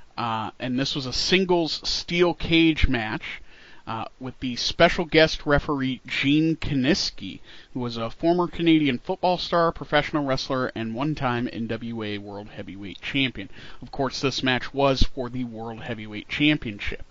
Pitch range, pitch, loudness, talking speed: 115-155 Hz, 130 Hz, -24 LUFS, 150 wpm